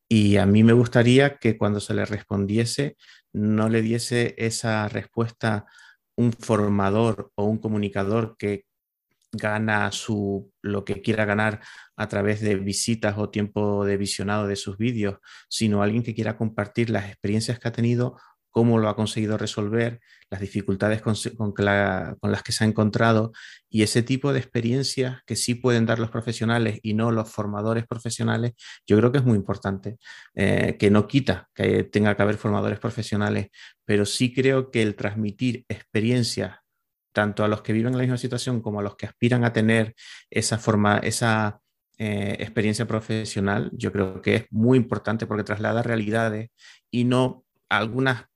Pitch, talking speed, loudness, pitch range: 110 Hz, 170 wpm, -24 LUFS, 105-115 Hz